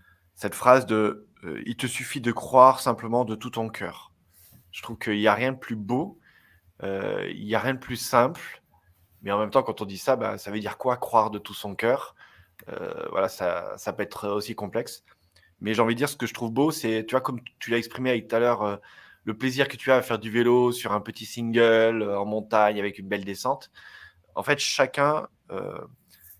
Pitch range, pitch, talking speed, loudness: 105-125 Hz, 115 Hz, 230 wpm, -25 LUFS